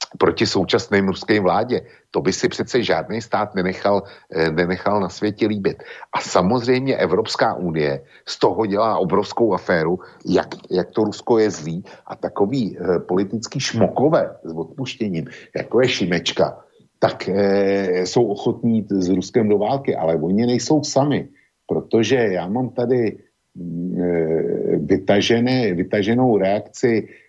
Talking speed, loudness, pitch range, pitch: 135 wpm, -20 LUFS, 90-120 Hz, 100 Hz